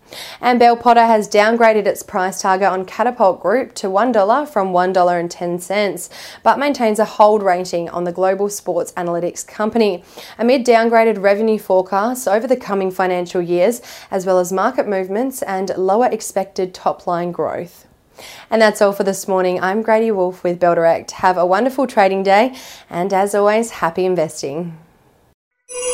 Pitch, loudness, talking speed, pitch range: 195 Hz, -16 LUFS, 155 wpm, 180-220 Hz